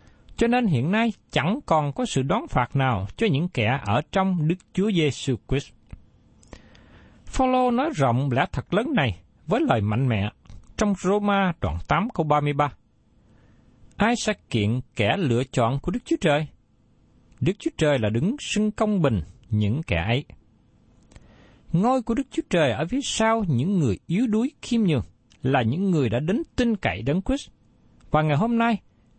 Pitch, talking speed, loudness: 145 Hz, 175 wpm, -24 LUFS